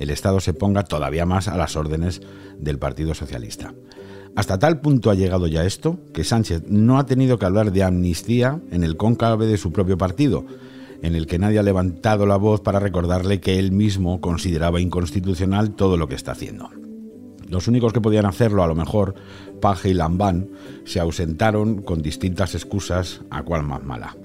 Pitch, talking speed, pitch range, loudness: 95 Hz, 185 wpm, 90-110 Hz, -20 LUFS